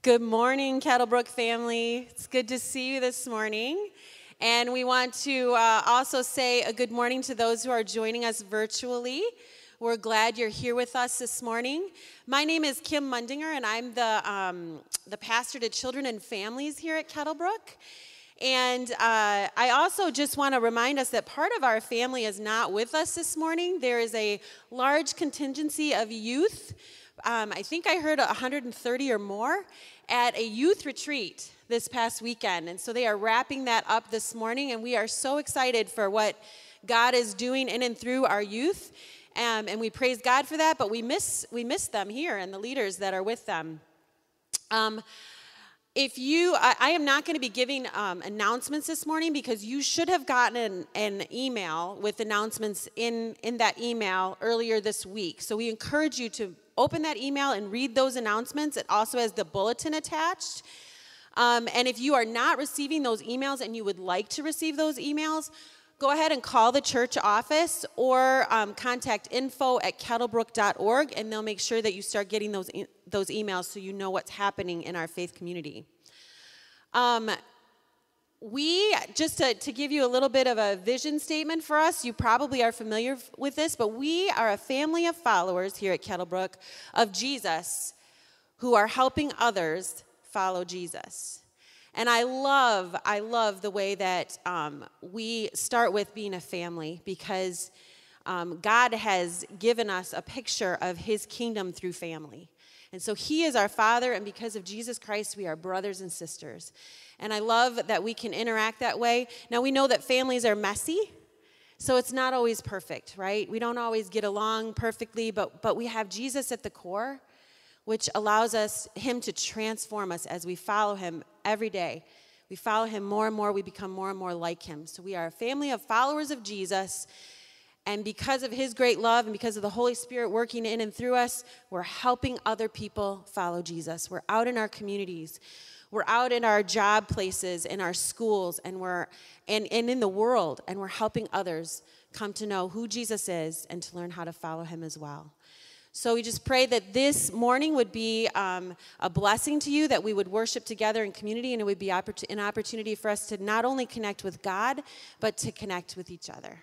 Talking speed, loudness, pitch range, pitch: 190 wpm, -28 LUFS, 205-255 Hz, 230 Hz